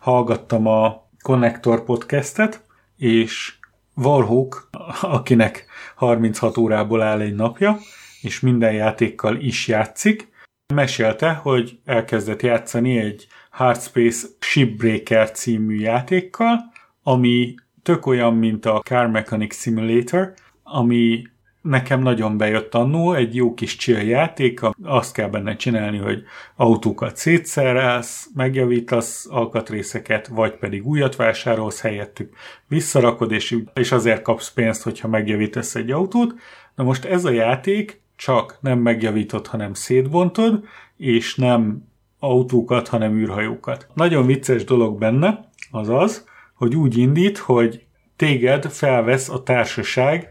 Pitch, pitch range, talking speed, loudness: 120 Hz, 110-135 Hz, 115 wpm, -19 LUFS